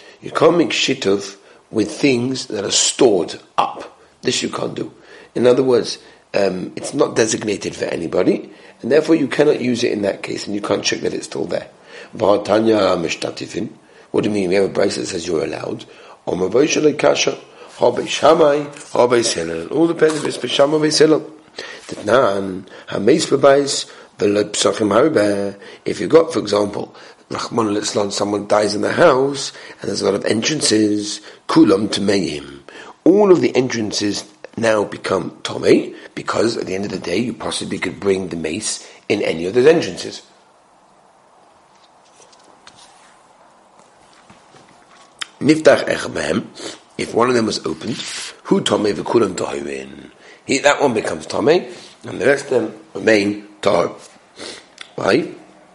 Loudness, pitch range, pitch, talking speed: -17 LUFS, 100-135 Hz, 105 Hz, 130 wpm